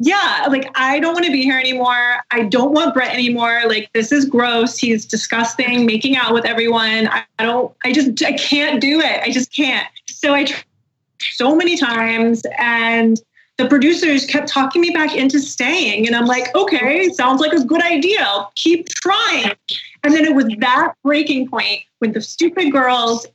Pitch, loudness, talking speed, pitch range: 260 Hz, -15 LUFS, 190 wpm, 235-300 Hz